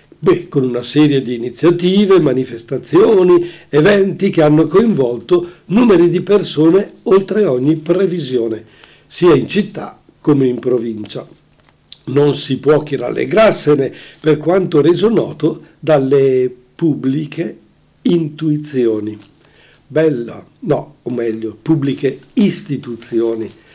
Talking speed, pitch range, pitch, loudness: 105 wpm, 130-175 Hz, 150 Hz, -14 LUFS